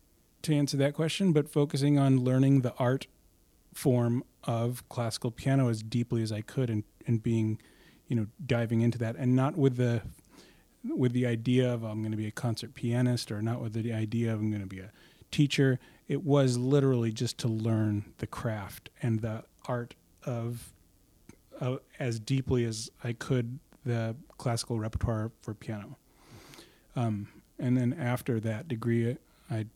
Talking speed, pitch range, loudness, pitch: 170 wpm, 110-130 Hz, -31 LUFS, 120 Hz